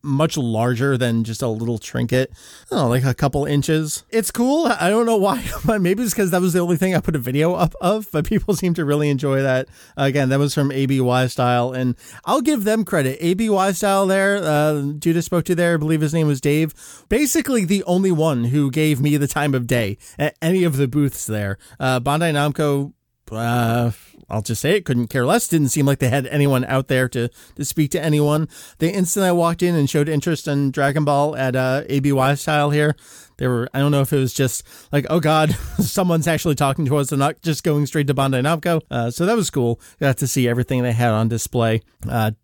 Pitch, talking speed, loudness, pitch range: 145 Hz, 230 wpm, -19 LUFS, 130-170 Hz